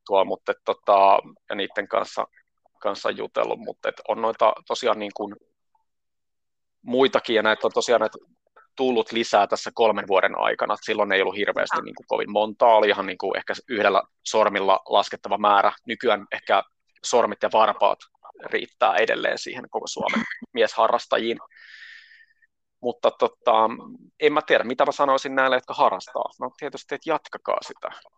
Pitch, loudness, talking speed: 190 Hz, -23 LUFS, 150 wpm